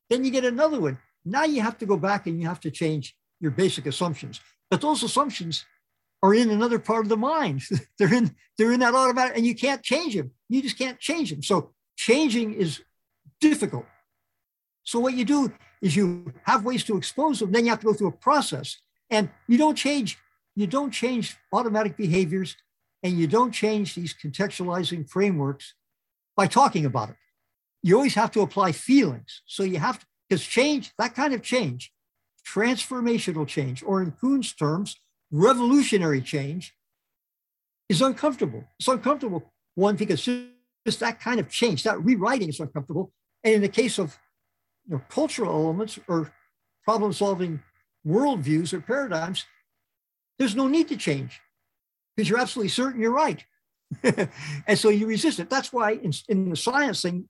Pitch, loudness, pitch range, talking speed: 215 Hz, -24 LUFS, 175-250 Hz, 175 wpm